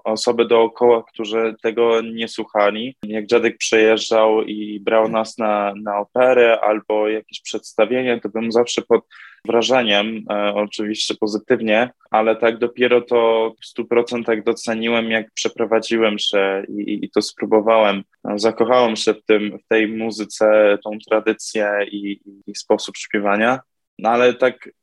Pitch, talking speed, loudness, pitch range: 110 Hz, 140 wpm, -18 LUFS, 105-115 Hz